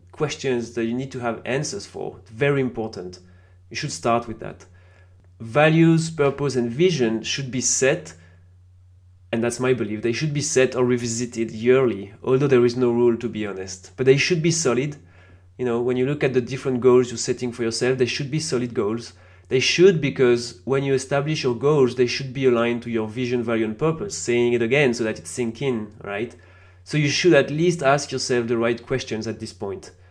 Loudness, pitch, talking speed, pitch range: -21 LUFS, 120 Hz, 210 wpm, 110-135 Hz